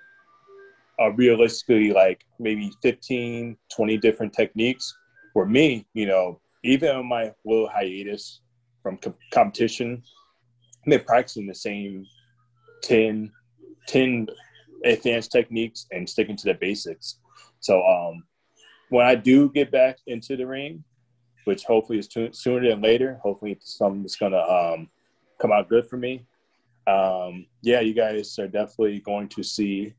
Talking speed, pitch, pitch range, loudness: 140 wpm, 115 Hz, 105-125 Hz, -23 LUFS